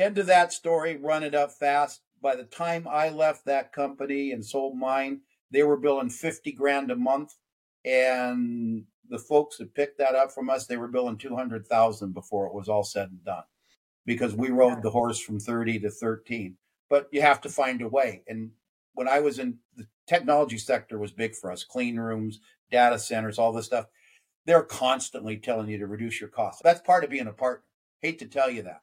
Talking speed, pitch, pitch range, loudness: 210 wpm, 125 Hz, 115-145 Hz, -26 LUFS